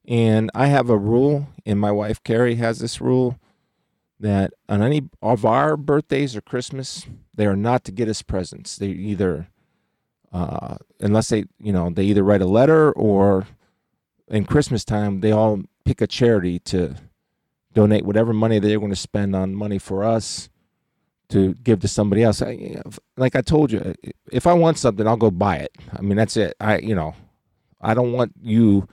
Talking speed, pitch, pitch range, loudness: 185 wpm, 110 Hz, 100-125 Hz, -20 LUFS